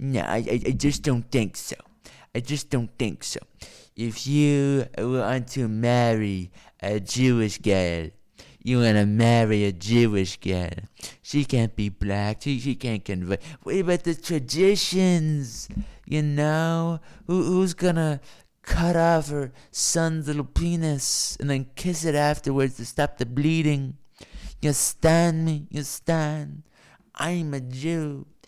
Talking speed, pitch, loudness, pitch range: 145 wpm, 140 Hz, -24 LUFS, 115-155 Hz